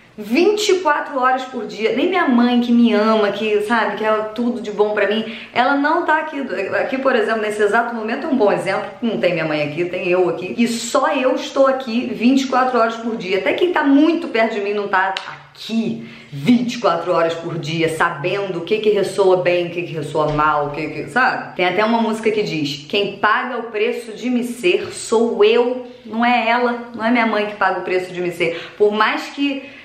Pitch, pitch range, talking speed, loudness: 220 Hz, 190-245 Hz, 225 wpm, -18 LUFS